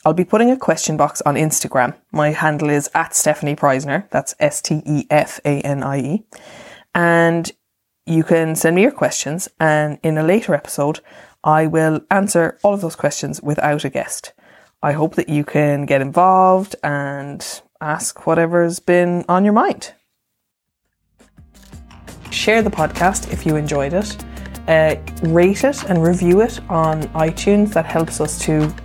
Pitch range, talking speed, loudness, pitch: 145-175 Hz, 150 wpm, -17 LUFS, 160 Hz